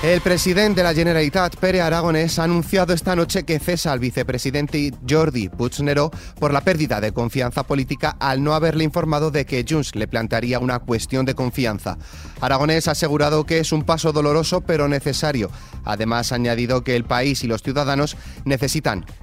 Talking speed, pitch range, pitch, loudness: 175 wpm, 125-160 Hz, 145 Hz, -20 LUFS